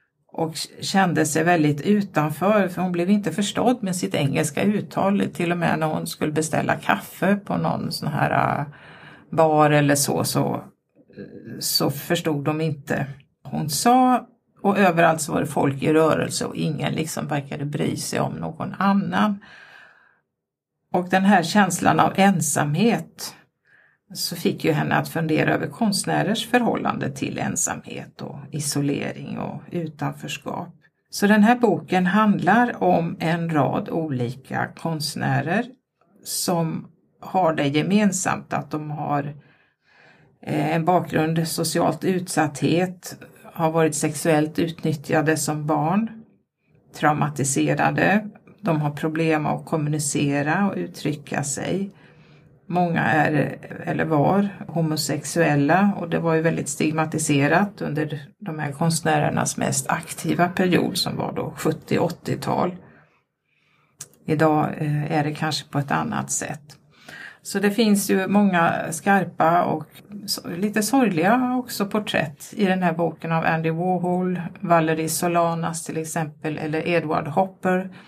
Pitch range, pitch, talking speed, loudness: 155-195 Hz, 165 Hz, 130 wpm, -22 LUFS